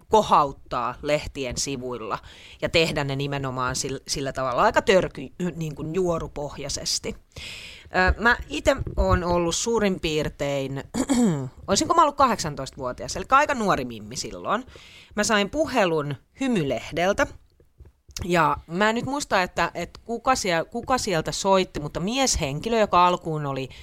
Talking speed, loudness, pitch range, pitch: 130 wpm, -24 LUFS, 135-210 Hz, 160 Hz